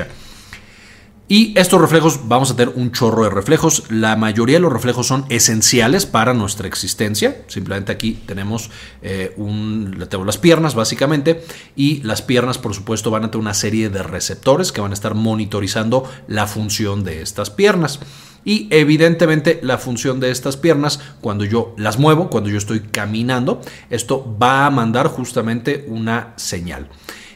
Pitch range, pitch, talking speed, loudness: 105-135 Hz, 115 Hz, 160 wpm, -16 LUFS